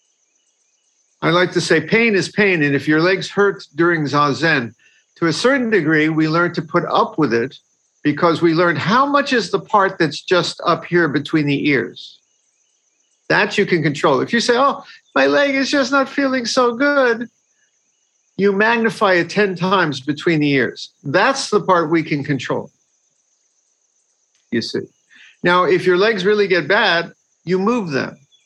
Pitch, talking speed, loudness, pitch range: 180 Hz, 175 wpm, -16 LUFS, 160-215 Hz